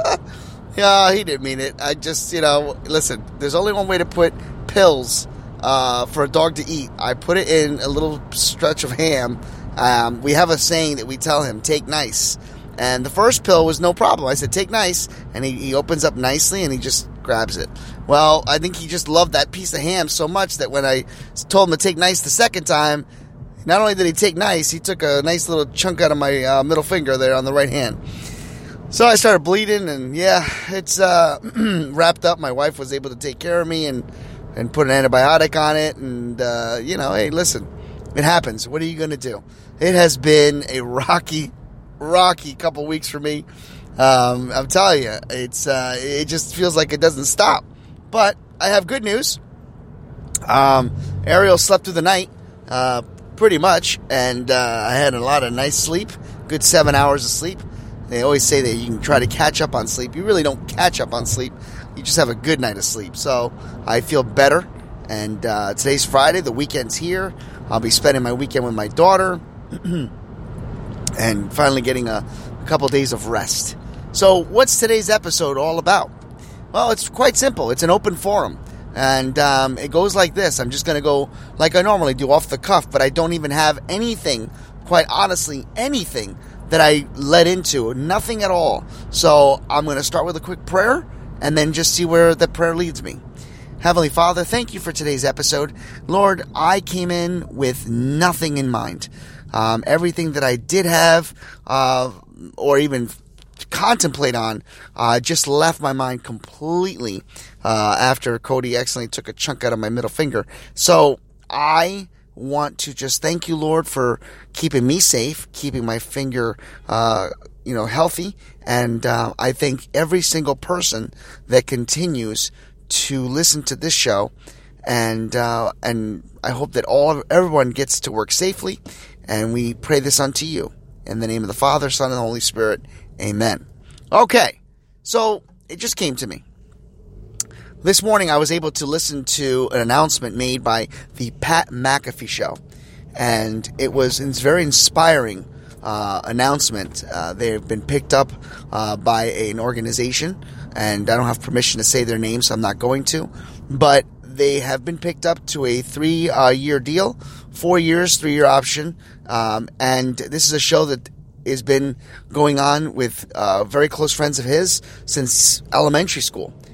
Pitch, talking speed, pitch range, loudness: 140 Hz, 190 wpm, 125-165 Hz, -17 LUFS